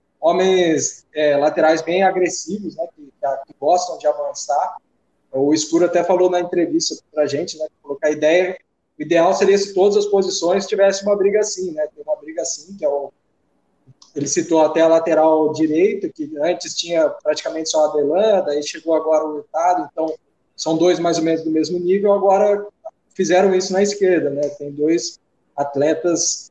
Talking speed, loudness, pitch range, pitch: 185 wpm, -18 LUFS, 155-190 Hz, 170 Hz